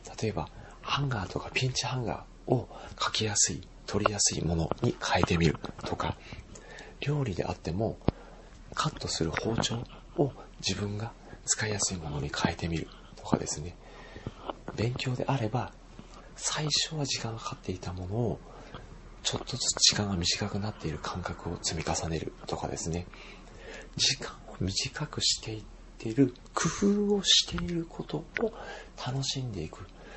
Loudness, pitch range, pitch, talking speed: -30 LUFS, 90-130 Hz, 105 Hz, 300 characters per minute